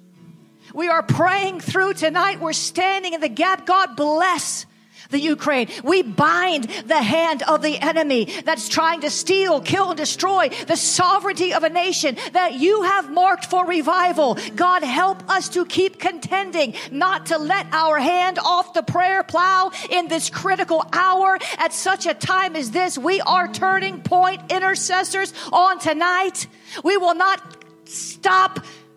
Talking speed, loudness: 155 wpm, -19 LUFS